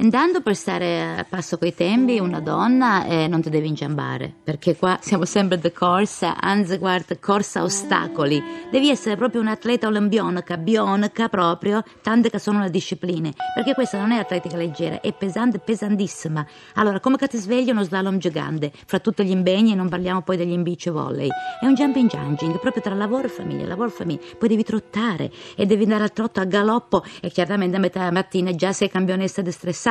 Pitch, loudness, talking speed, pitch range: 195 Hz, -21 LUFS, 195 wpm, 175-220 Hz